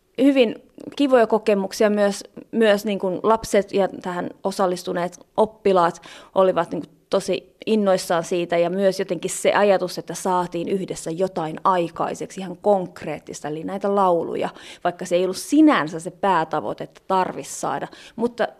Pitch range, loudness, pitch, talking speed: 175-210 Hz, -22 LUFS, 190 Hz, 140 wpm